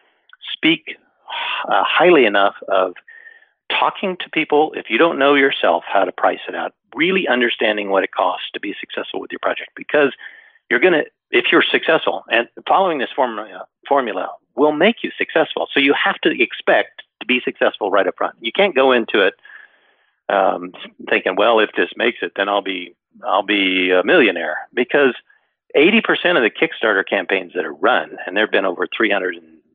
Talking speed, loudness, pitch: 180 wpm, -17 LUFS, 330 Hz